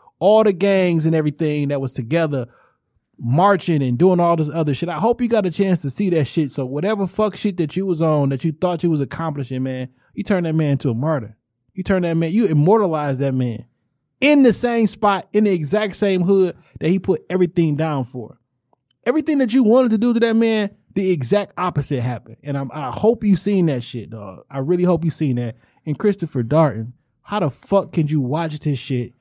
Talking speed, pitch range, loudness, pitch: 225 wpm, 135-195 Hz, -19 LUFS, 165 Hz